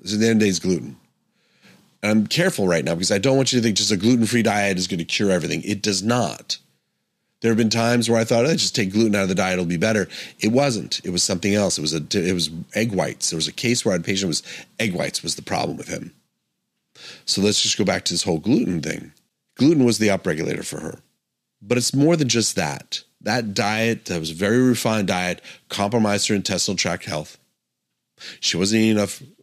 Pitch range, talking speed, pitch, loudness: 95-115 Hz, 250 wpm, 105 Hz, -20 LUFS